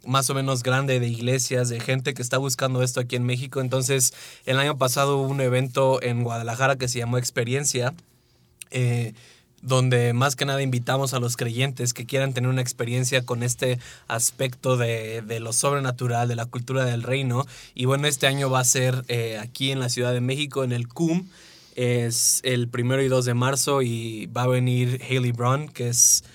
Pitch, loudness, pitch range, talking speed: 125 Hz, -23 LUFS, 120-135 Hz, 195 wpm